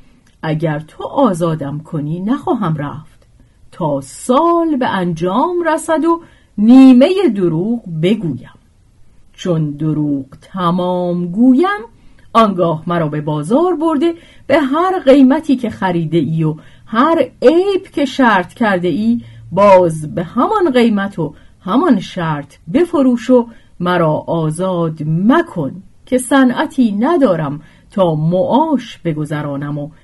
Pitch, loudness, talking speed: 185 Hz, -14 LUFS, 110 wpm